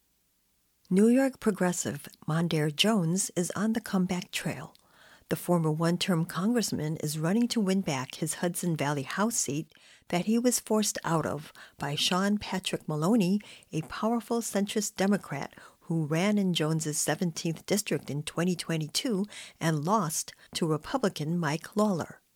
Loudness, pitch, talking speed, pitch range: -29 LUFS, 180 Hz, 140 wpm, 160-210 Hz